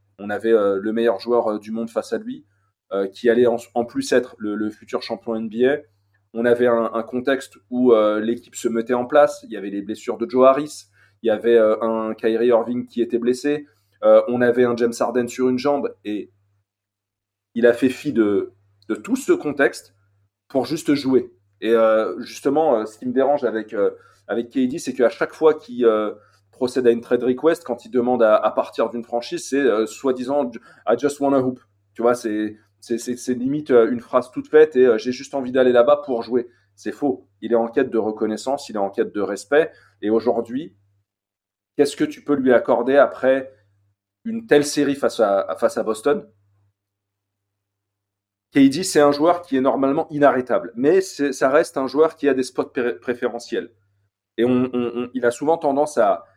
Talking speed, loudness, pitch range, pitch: 210 wpm, -20 LUFS, 105-135 Hz, 120 Hz